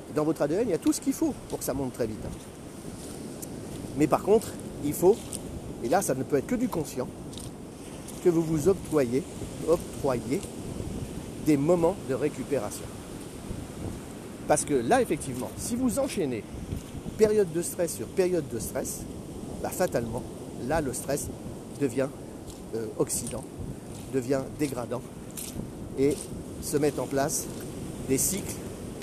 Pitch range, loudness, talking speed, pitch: 125-180 Hz, -29 LUFS, 145 wpm, 145 Hz